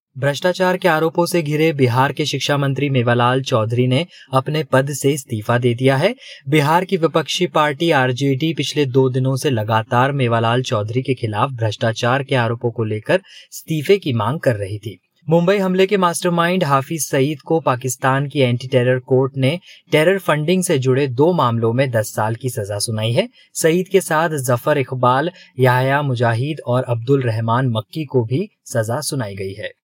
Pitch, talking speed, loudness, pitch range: 135 Hz, 175 wpm, -18 LUFS, 125-155 Hz